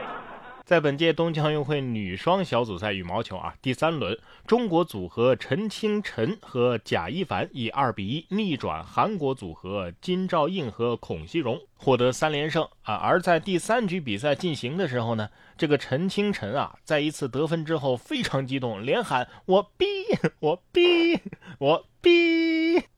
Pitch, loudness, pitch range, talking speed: 155 Hz, -25 LUFS, 125-190 Hz, 250 characters per minute